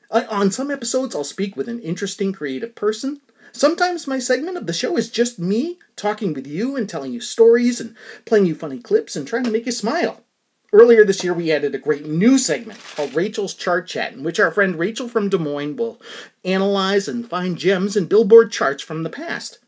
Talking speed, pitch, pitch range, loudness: 215 wpm, 220 Hz, 190-245 Hz, -19 LUFS